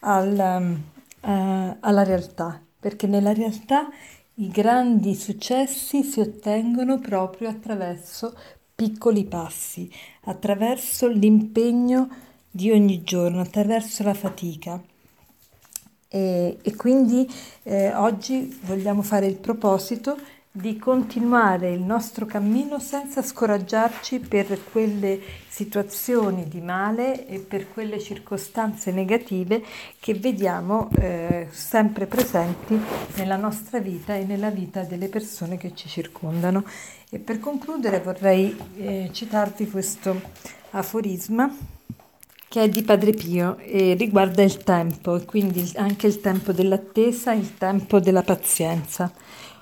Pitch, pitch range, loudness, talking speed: 205 Hz, 190-225 Hz, -23 LUFS, 110 wpm